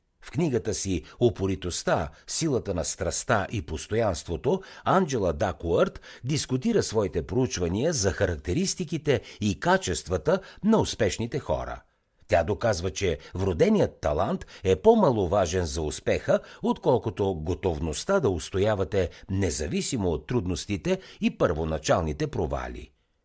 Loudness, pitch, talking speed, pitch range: -26 LUFS, 95 Hz, 105 wpm, 85-125 Hz